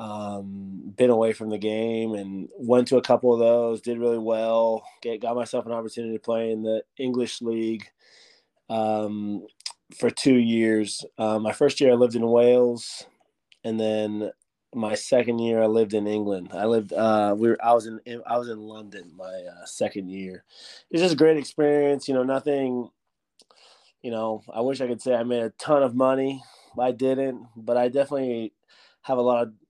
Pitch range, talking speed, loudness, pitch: 110-125 Hz, 190 wpm, -24 LUFS, 115 Hz